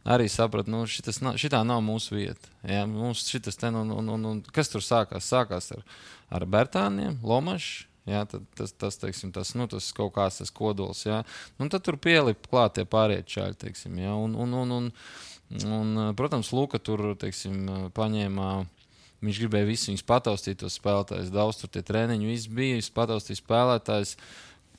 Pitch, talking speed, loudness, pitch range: 110 Hz, 135 wpm, -28 LUFS, 100-120 Hz